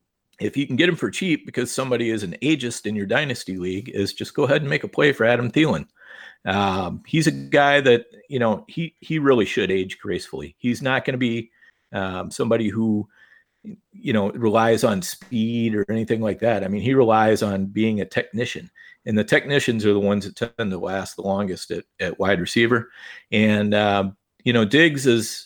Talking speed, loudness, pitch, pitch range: 205 wpm, -21 LUFS, 115 Hz, 105-130 Hz